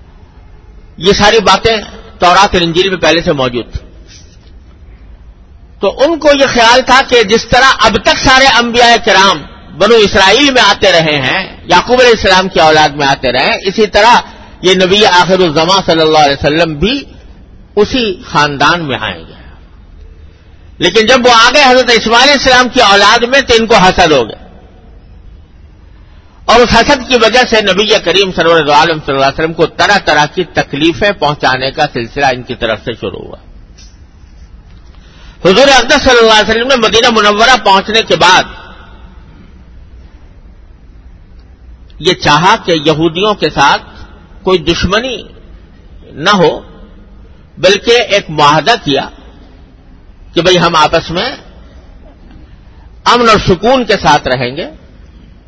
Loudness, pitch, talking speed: -8 LUFS, 160 Hz, 145 wpm